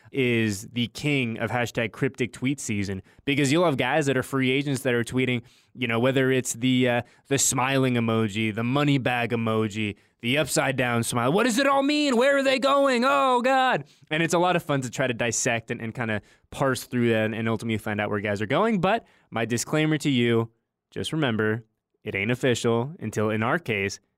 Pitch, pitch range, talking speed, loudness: 125 Hz, 115-140 Hz, 215 wpm, -24 LUFS